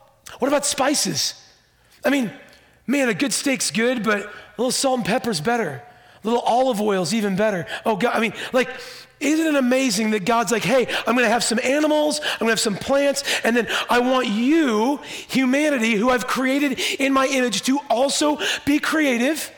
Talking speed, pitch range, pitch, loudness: 185 wpm, 225-275 Hz, 255 Hz, -20 LUFS